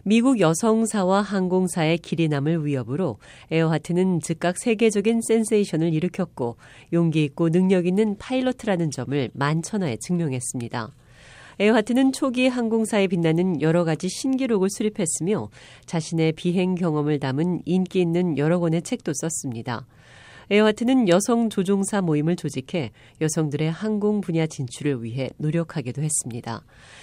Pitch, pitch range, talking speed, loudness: 170 Hz, 150-200 Hz, 340 characters per minute, -23 LUFS